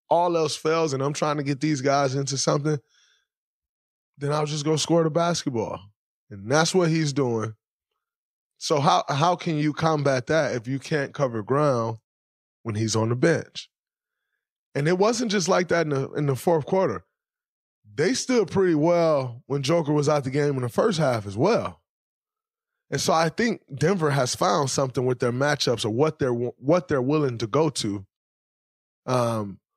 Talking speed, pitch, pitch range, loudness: 180 wpm, 145 Hz, 125-165 Hz, -24 LUFS